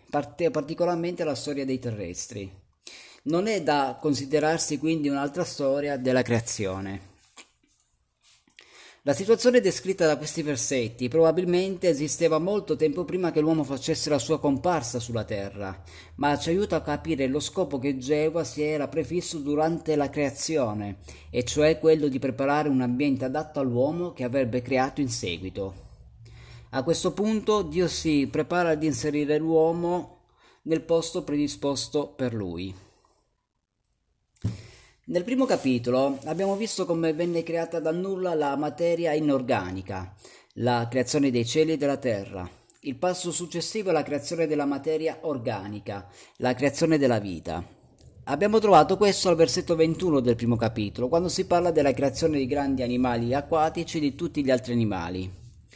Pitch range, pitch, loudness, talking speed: 125-165 Hz, 145 Hz, -25 LUFS, 145 wpm